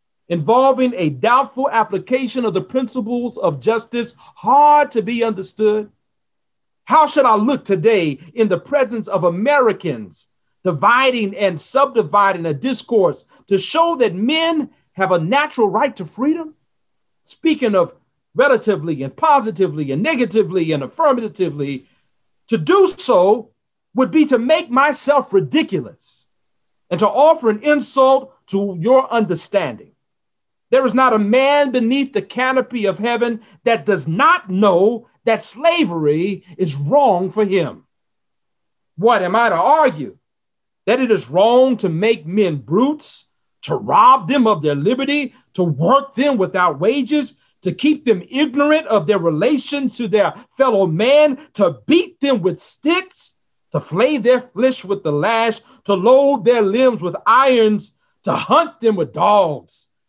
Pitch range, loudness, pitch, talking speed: 195-275 Hz, -16 LUFS, 230 Hz, 140 wpm